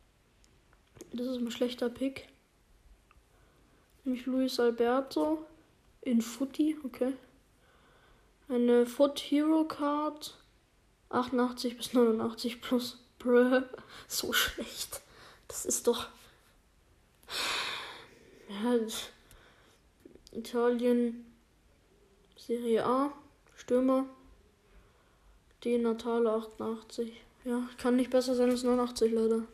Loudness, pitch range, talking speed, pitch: -31 LUFS, 235-260 Hz, 85 wpm, 245 Hz